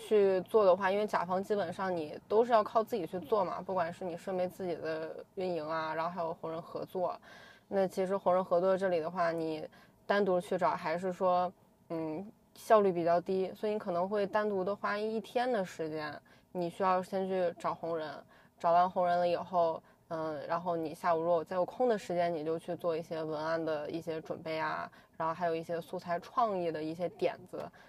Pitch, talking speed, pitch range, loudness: 175 Hz, 300 characters per minute, 165-190 Hz, -33 LUFS